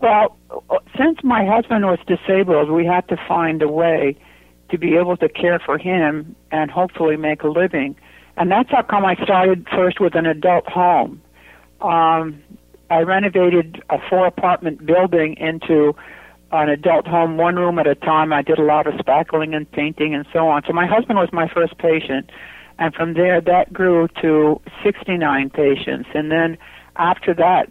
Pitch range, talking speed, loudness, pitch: 155-180 Hz, 175 wpm, -17 LUFS, 165 Hz